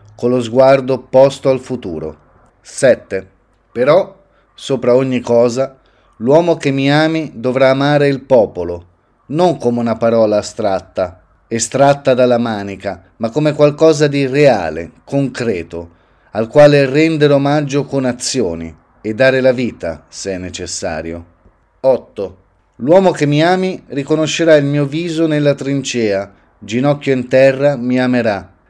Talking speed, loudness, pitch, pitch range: 130 wpm, -14 LUFS, 130 Hz, 105-145 Hz